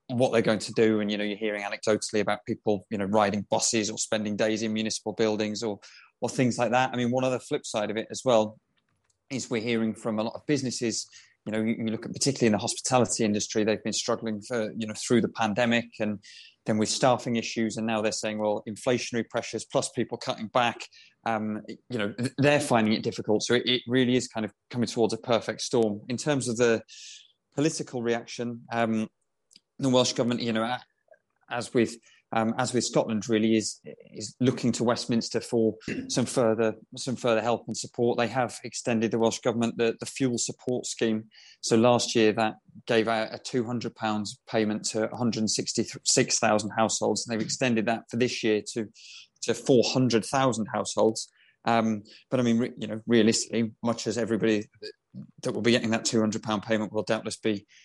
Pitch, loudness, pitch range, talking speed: 115 Hz, -27 LUFS, 110-120 Hz, 205 wpm